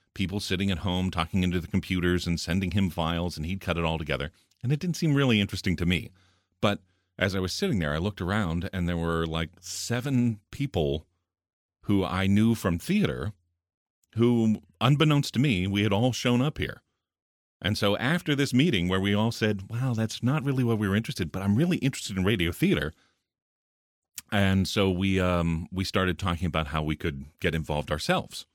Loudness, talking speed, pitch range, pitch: -27 LUFS, 200 wpm, 85-110 Hz, 95 Hz